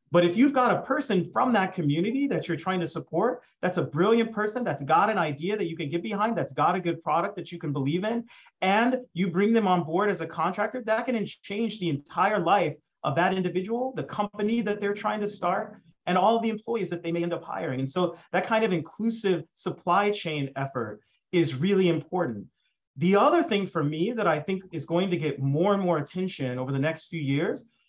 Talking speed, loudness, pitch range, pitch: 230 wpm, -27 LUFS, 165-210 Hz, 180 Hz